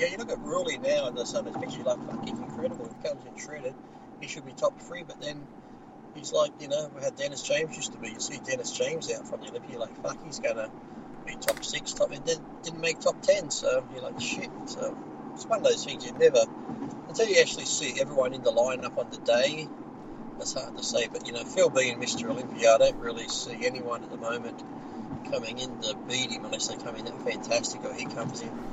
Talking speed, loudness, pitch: 240 wpm, -30 LUFS, 290 Hz